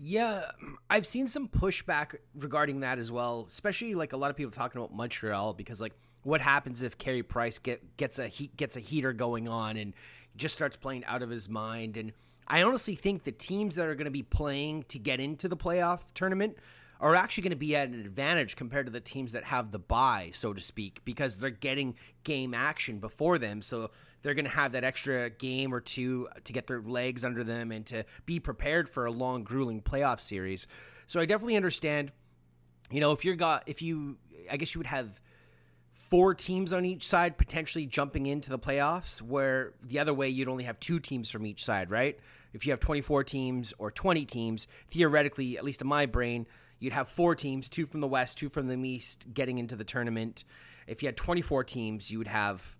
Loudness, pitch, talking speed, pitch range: -32 LUFS, 135 Hz, 215 wpm, 115-150 Hz